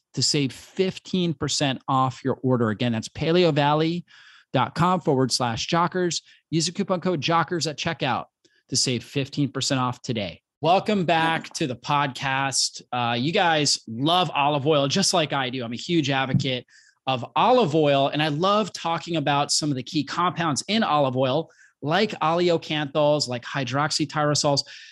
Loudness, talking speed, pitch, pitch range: -23 LUFS, 150 wpm, 150 Hz, 135-165 Hz